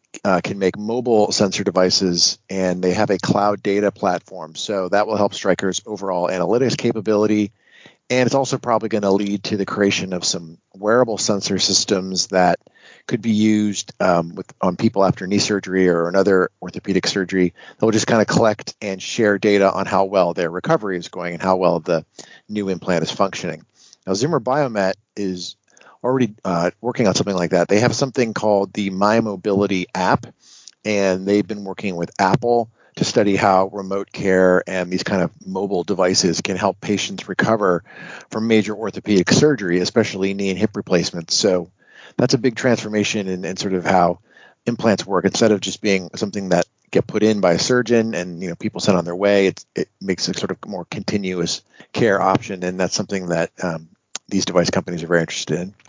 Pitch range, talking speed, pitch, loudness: 90-105 Hz, 190 wpm, 100 Hz, -19 LUFS